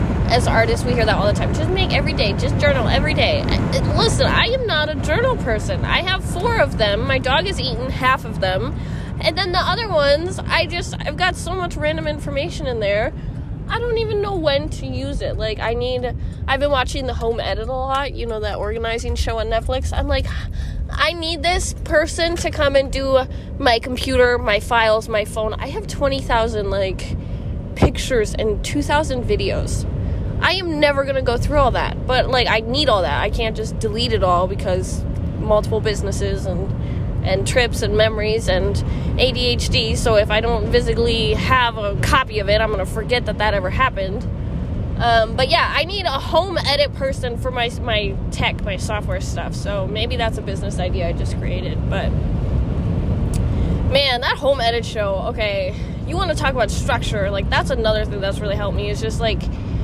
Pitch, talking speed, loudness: 260 Hz, 200 wpm, -19 LUFS